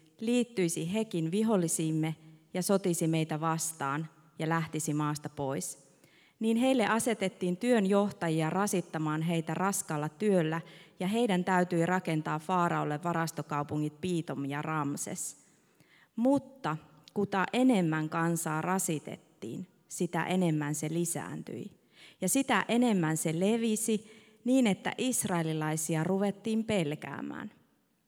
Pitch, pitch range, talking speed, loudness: 170 Hz, 155-200 Hz, 100 wpm, -31 LUFS